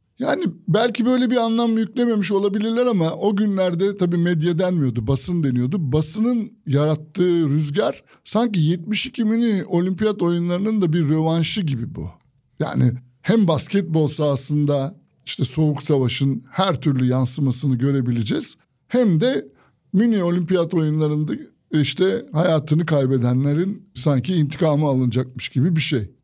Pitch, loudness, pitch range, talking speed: 165 Hz, -20 LUFS, 145-200 Hz, 120 wpm